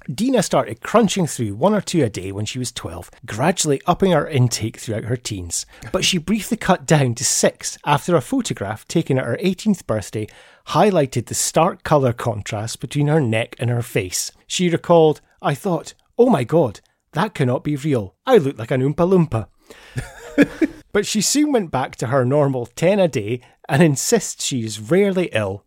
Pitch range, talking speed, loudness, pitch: 120-185 Hz, 185 wpm, -19 LUFS, 145 Hz